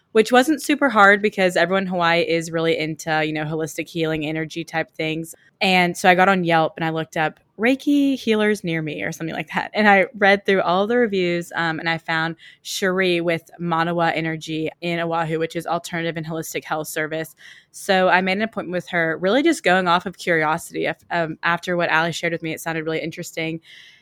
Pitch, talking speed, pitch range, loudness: 170 Hz, 210 wpm, 160-190 Hz, -20 LUFS